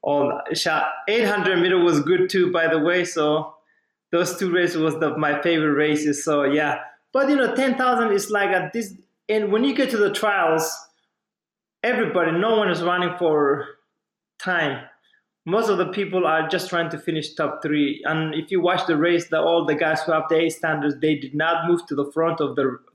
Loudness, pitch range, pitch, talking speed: -21 LUFS, 155-185 Hz, 170 Hz, 205 wpm